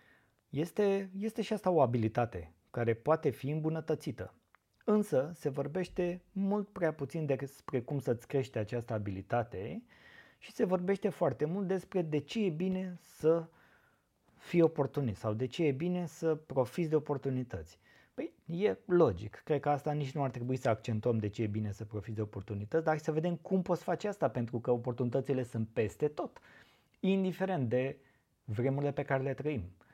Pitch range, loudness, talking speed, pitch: 120-175 Hz, -34 LUFS, 170 wpm, 145 Hz